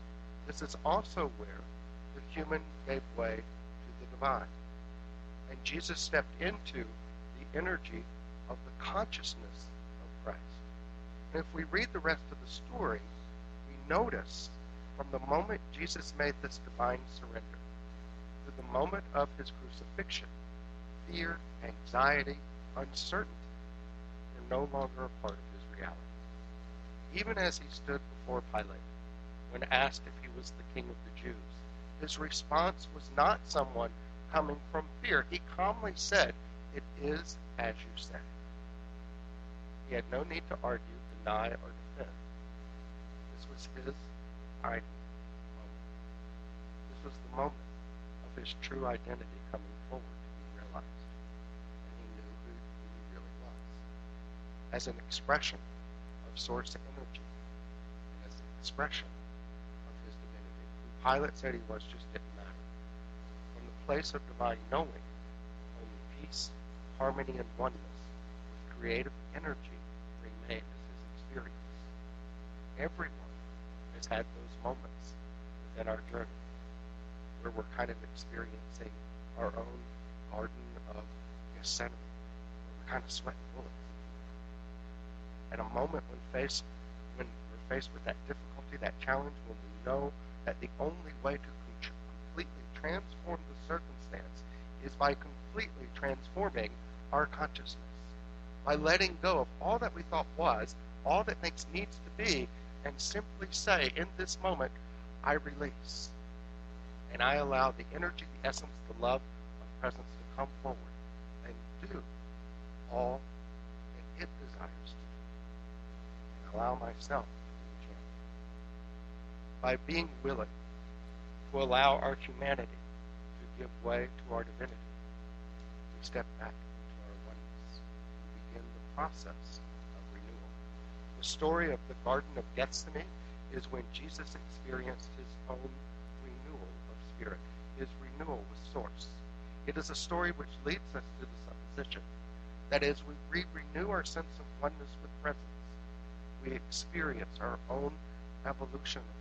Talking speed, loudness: 135 wpm, -39 LUFS